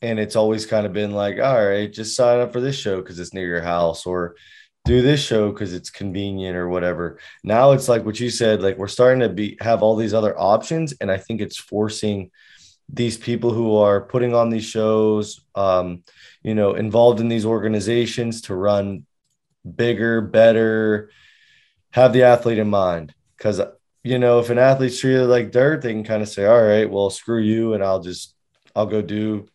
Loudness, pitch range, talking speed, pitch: -19 LUFS, 100-120 Hz, 200 wpm, 110 Hz